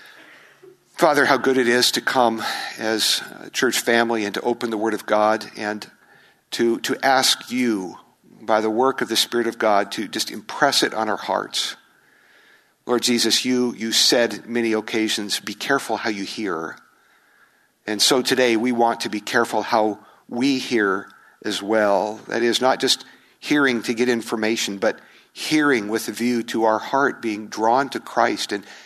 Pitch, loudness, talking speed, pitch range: 115 Hz, -20 LUFS, 175 wpm, 110-125 Hz